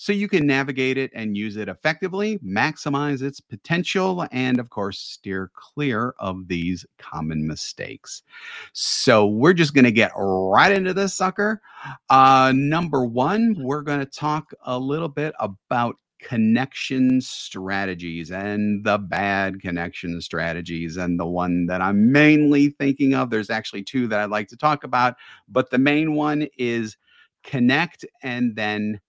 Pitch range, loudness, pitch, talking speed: 100-145 Hz, -21 LUFS, 125 Hz, 150 wpm